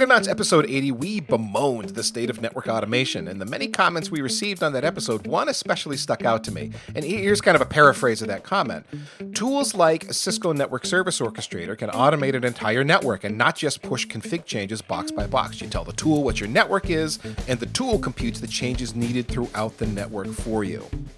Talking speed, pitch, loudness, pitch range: 215 wpm, 130 Hz, -23 LUFS, 110-175 Hz